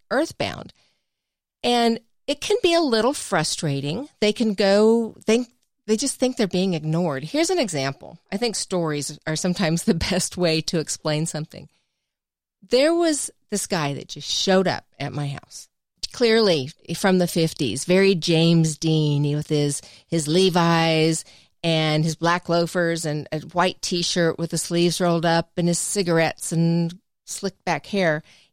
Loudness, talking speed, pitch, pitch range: -22 LUFS, 160 wpm, 170 Hz, 160-205 Hz